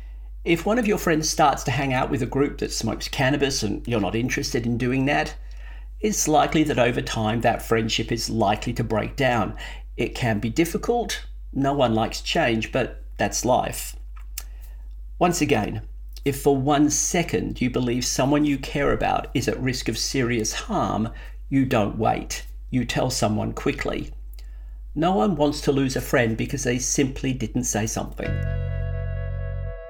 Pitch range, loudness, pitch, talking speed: 105-140 Hz, -23 LUFS, 120 Hz, 165 wpm